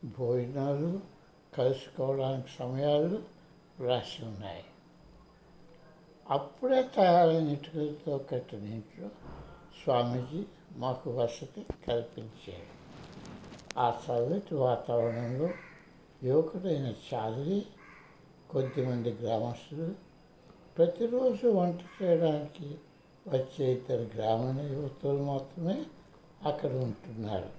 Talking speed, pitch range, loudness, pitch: 65 wpm, 125-165 Hz, -32 LUFS, 140 Hz